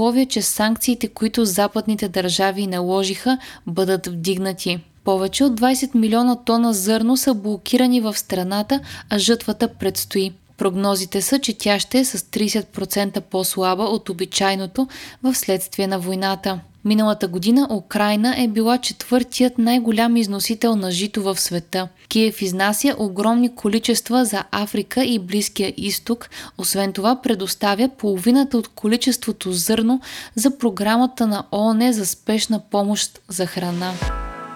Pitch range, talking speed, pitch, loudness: 195-235 Hz, 125 wpm, 215 Hz, -20 LUFS